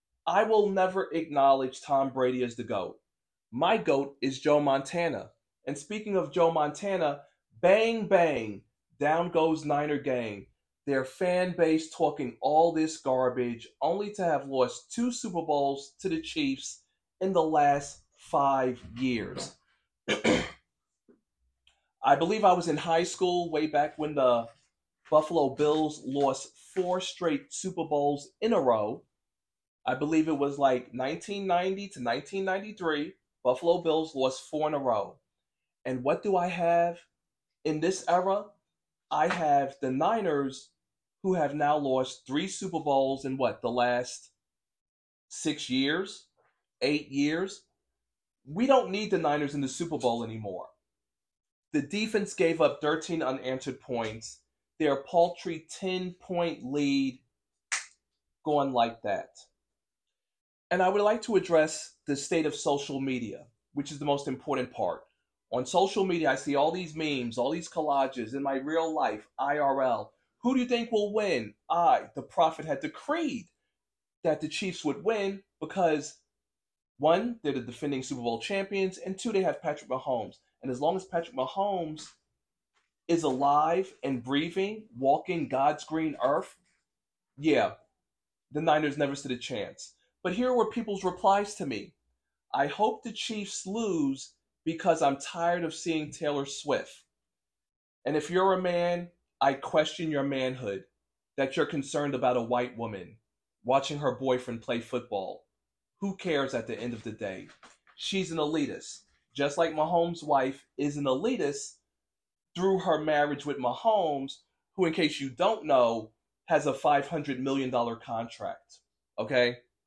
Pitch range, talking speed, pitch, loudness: 135-180 Hz, 145 wpm, 150 Hz, -29 LUFS